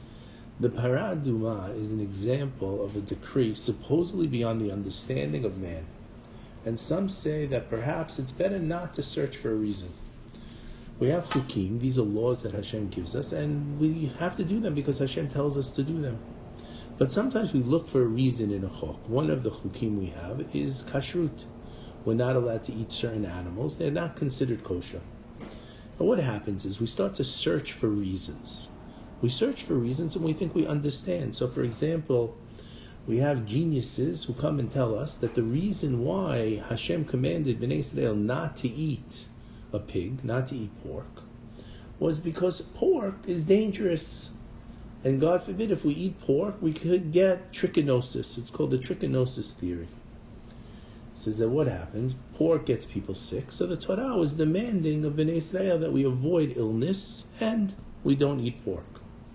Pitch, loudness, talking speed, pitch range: 125 Hz, -29 LUFS, 175 wpm, 115-155 Hz